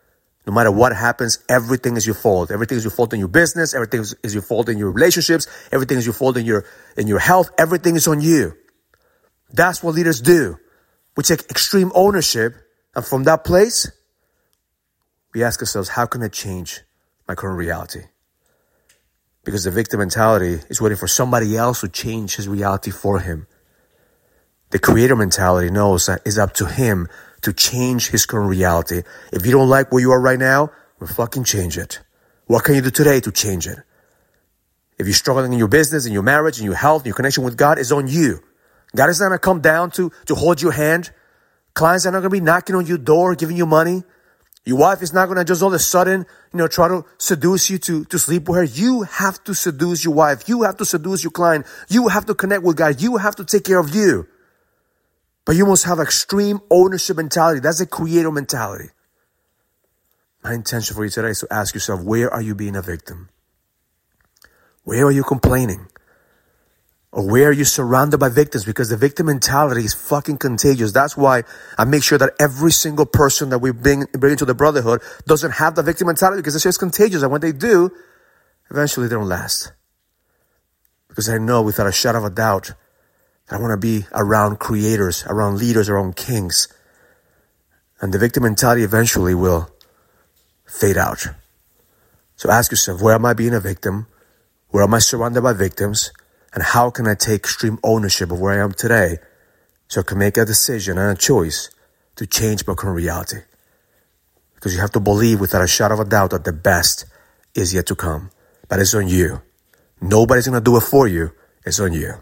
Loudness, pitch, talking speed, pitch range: -16 LUFS, 120 Hz, 200 wpm, 105-160 Hz